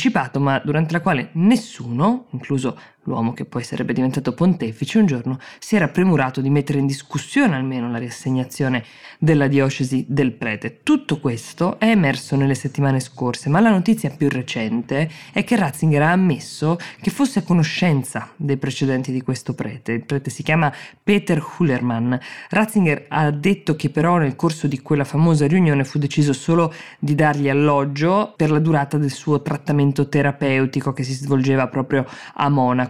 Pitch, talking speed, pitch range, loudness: 145 Hz, 165 wpm, 130-165 Hz, -19 LUFS